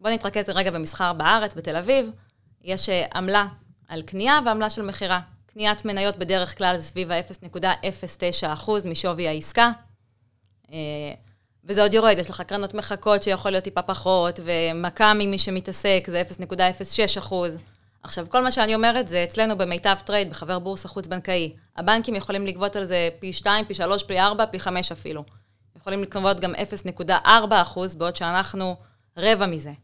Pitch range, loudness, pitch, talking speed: 170-205 Hz, -22 LUFS, 185 Hz, 145 wpm